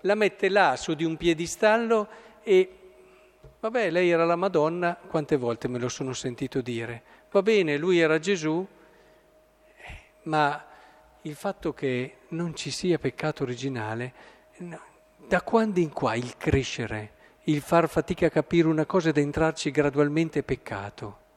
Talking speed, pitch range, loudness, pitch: 150 wpm, 135-175 Hz, -26 LUFS, 155 Hz